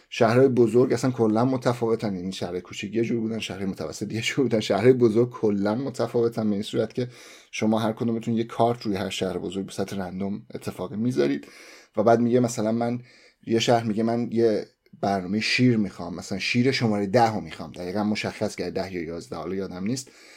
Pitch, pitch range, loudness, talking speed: 110 Hz, 100-120 Hz, -25 LUFS, 195 wpm